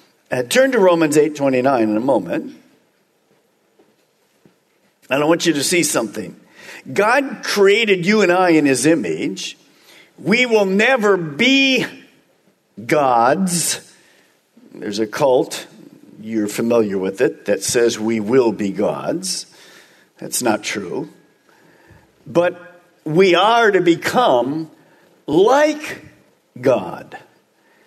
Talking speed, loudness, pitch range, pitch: 110 wpm, -16 LUFS, 135-225 Hz, 175 Hz